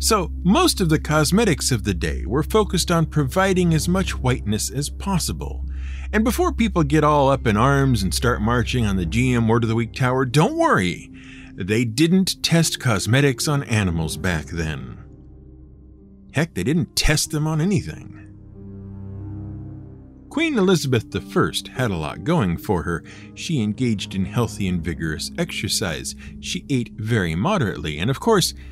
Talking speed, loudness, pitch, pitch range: 160 wpm, -21 LUFS, 115 Hz, 95-150 Hz